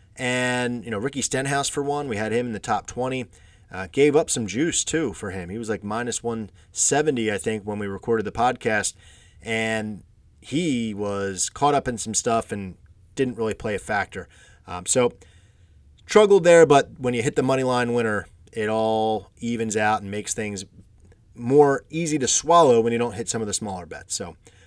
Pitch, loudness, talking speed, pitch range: 110 Hz, -23 LUFS, 200 wpm, 95-125 Hz